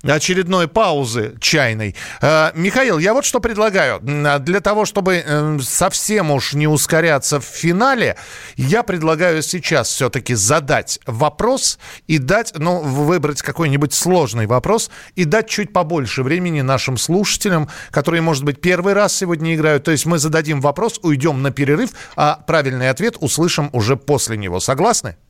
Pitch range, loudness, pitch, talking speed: 140-185 Hz, -16 LUFS, 155 Hz, 145 wpm